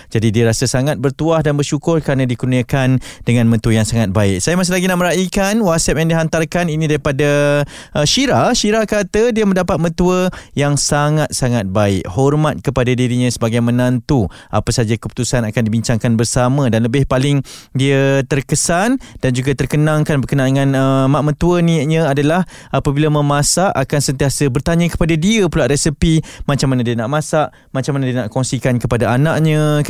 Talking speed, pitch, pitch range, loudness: 160 wpm, 145 Hz, 125-160 Hz, -15 LUFS